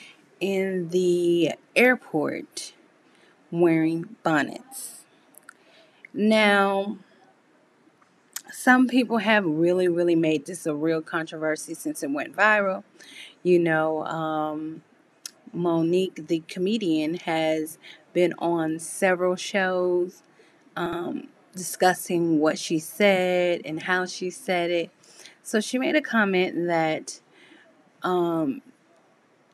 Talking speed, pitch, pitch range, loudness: 100 wpm, 180 Hz, 165-215 Hz, -24 LUFS